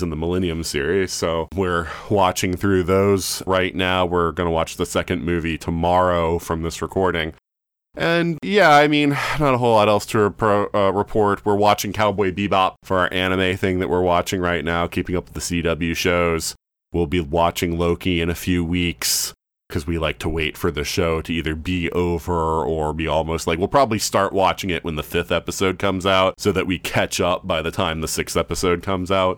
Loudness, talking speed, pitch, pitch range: -20 LUFS, 210 wpm, 90 Hz, 85-95 Hz